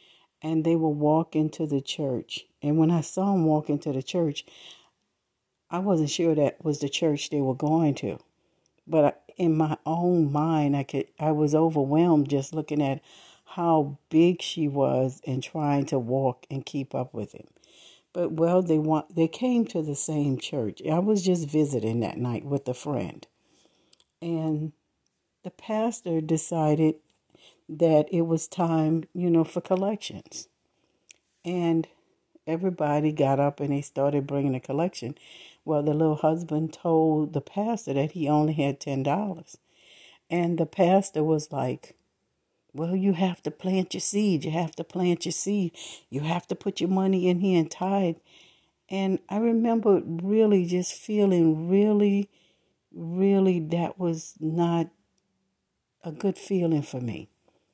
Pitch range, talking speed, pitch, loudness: 150-180 Hz, 155 wpm, 160 Hz, -26 LUFS